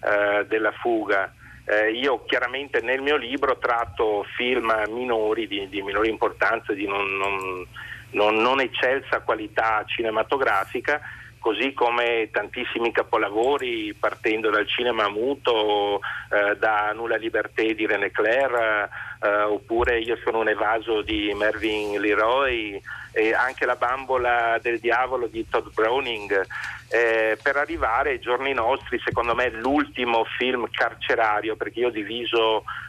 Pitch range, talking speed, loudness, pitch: 105-130 Hz, 130 wpm, -23 LUFS, 115 Hz